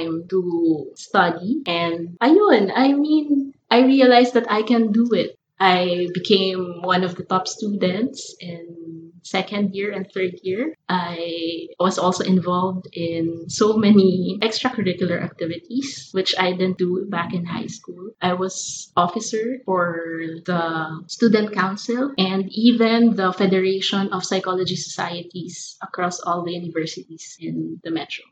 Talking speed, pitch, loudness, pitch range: 135 wpm, 185 Hz, -20 LUFS, 175-210 Hz